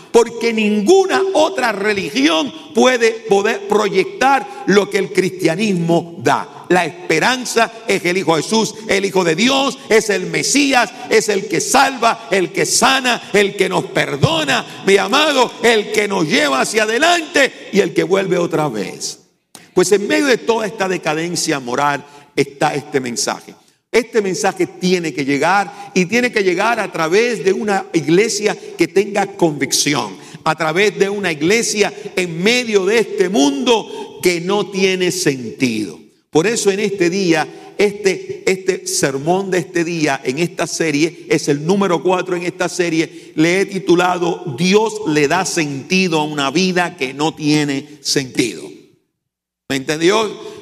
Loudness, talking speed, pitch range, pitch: -16 LUFS, 155 wpm, 165-225 Hz, 190 Hz